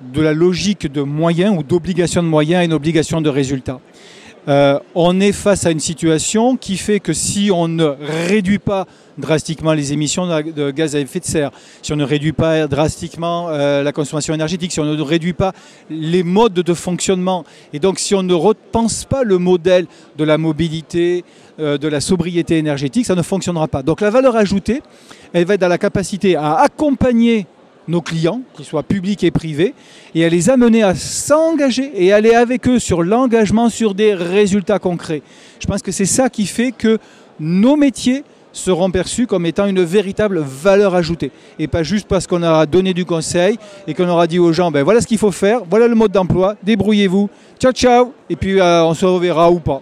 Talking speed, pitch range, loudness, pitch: 200 wpm, 160-205 Hz, -15 LUFS, 180 Hz